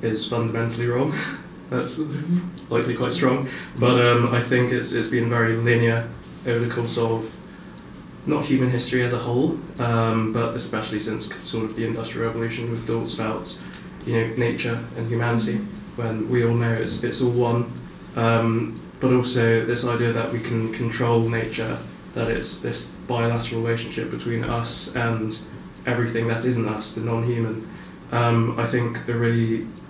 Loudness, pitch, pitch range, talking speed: -23 LUFS, 115 Hz, 115-120 Hz, 160 wpm